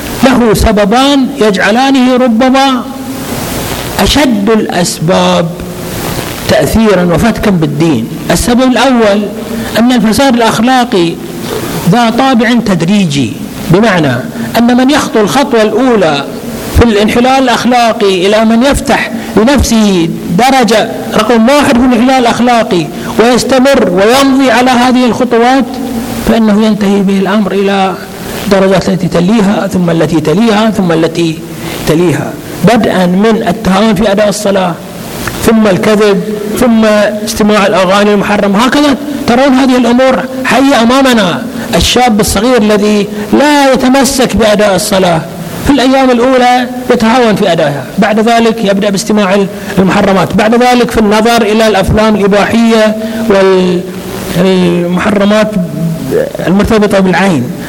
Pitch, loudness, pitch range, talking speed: 215 Hz, -8 LUFS, 195-245 Hz, 105 wpm